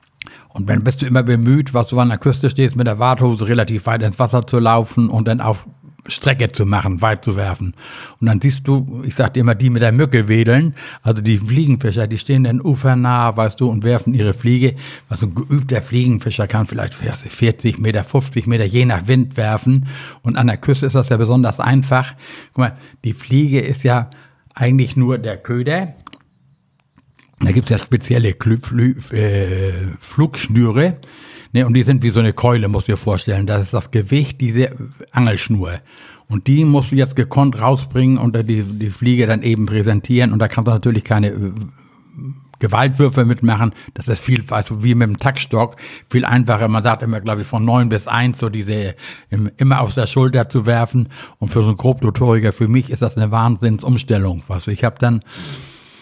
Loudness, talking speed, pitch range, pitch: -16 LUFS, 185 wpm, 110-130 Hz, 120 Hz